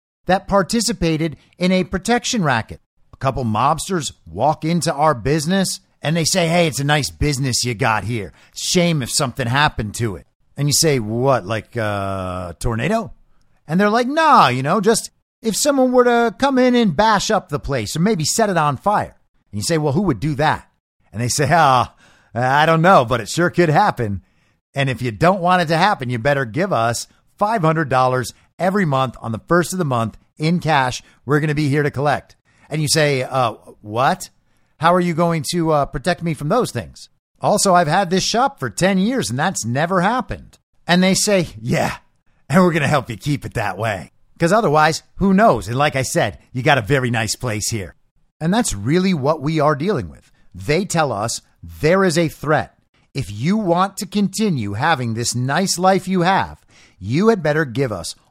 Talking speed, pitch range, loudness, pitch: 205 wpm, 125-185 Hz, -18 LUFS, 155 Hz